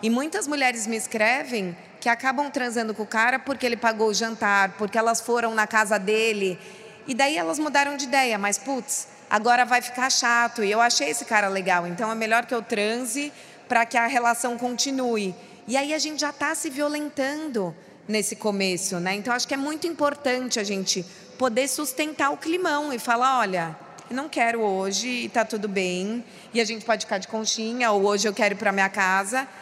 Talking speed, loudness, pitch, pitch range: 205 wpm, -24 LUFS, 235 Hz, 210-265 Hz